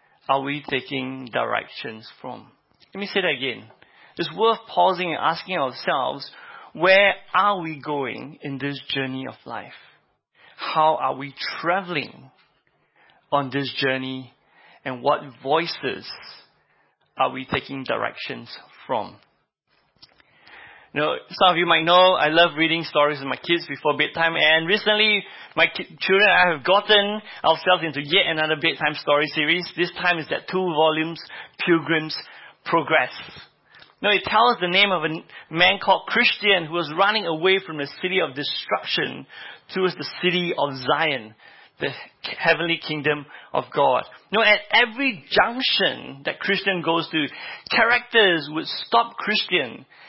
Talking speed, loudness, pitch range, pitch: 145 wpm, -21 LUFS, 145-190 Hz, 165 Hz